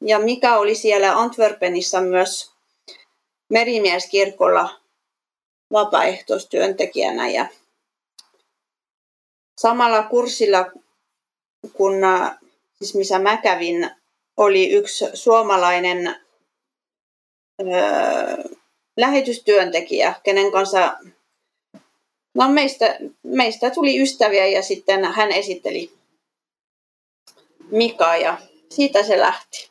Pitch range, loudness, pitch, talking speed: 190-245 Hz, -18 LUFS, 210 Hz, 75 wpm